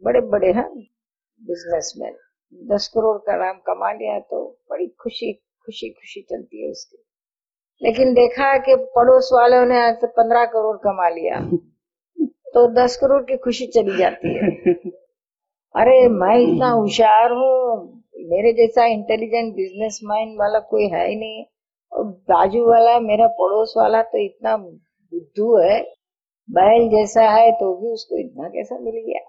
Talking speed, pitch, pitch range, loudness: 150 wpm, 230 Hz, 210-260 Hz, -17 LUFS